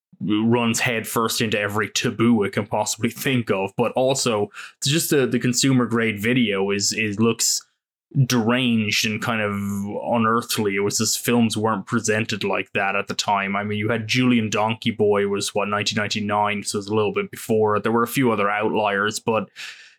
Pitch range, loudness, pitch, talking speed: 105-120 Hz, -21 LUFS, 110 Hz, 190 wpm